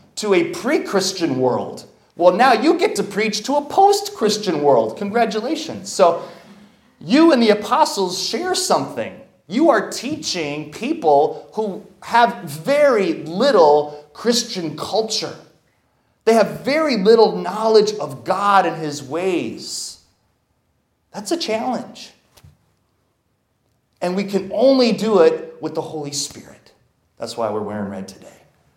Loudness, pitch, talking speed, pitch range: -18 LUFS, 205 Hz, 130 wpm, 160-240 Hz